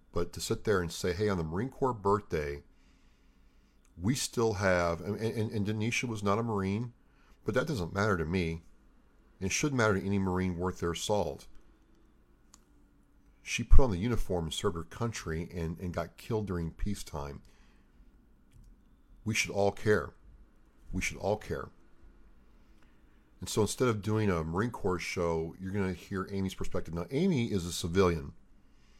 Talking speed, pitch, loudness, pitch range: 170 wpm, 95 Hz, -32 LUFS, 85-105 Hz